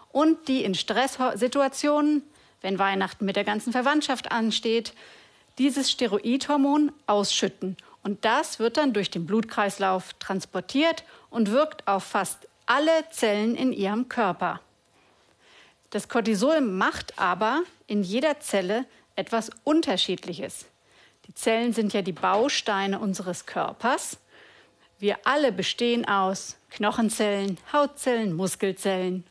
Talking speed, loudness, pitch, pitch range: 115 wpm, -25 LUFS, 220 Hz, 195-270 Hz